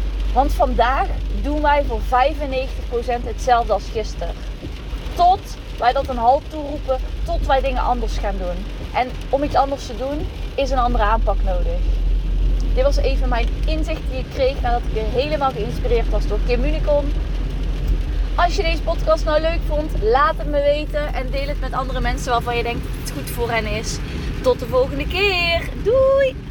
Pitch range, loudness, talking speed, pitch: 235-315 Hz, -21 LUFS, 180 wpm, 275 Hz